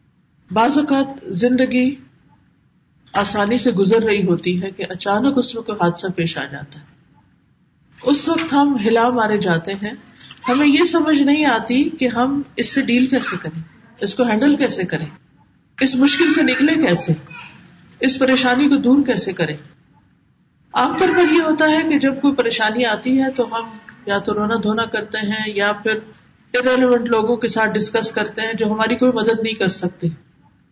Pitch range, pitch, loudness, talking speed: 195-260 Hz, 225 Hz, -17 LUFS, 175 wpm